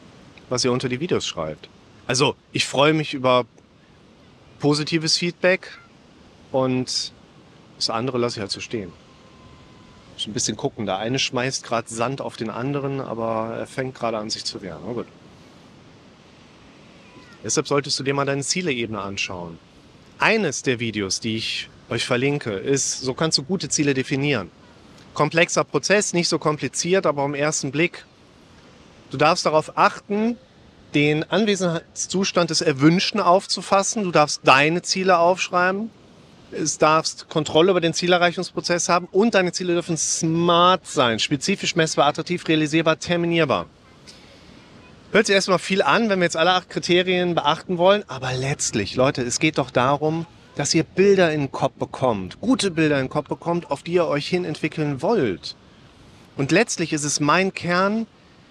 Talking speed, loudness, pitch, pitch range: 155 wpm, -21 LUFS, 155 Hz, 130-175 Hz